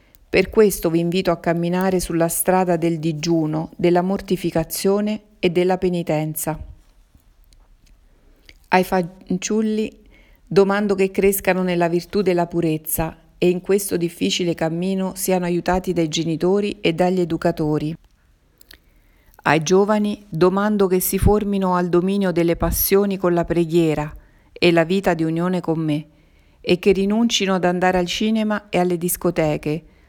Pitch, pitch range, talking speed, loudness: 180 Hz, 165-195 Hz, 130 wpm, -20 LUFS